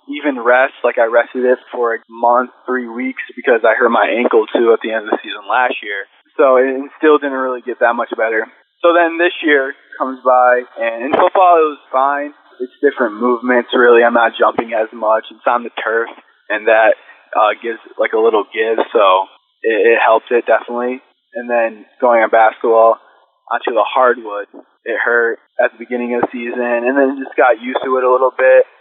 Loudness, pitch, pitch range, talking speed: -14 LUFS, 130 Hz, 120-155 Hz, 210 wpm